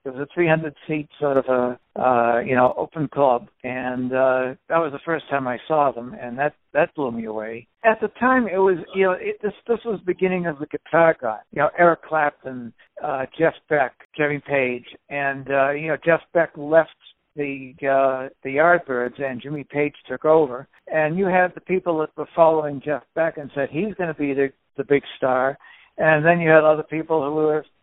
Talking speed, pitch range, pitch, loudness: 215 wpm, 135-165 Hz, 150 Hz, -21 LUFS